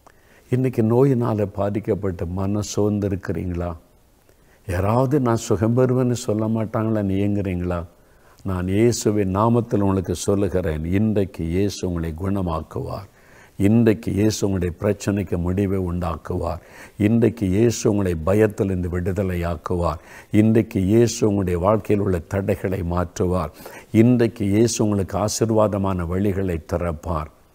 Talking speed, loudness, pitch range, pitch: 100 wpm, -21 LUFS, 90-110 Hz, 100 Hz